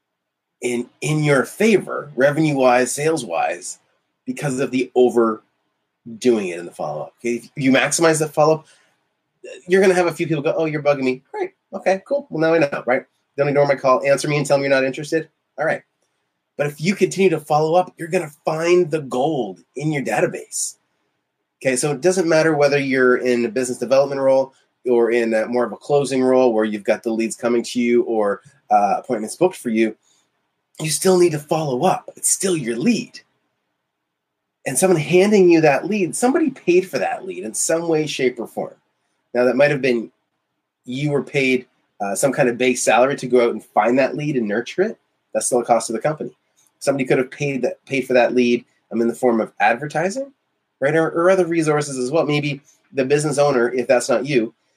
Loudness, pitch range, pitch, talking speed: -19 LUFS, 125-165 Hz, 145 Hz, 215 wpm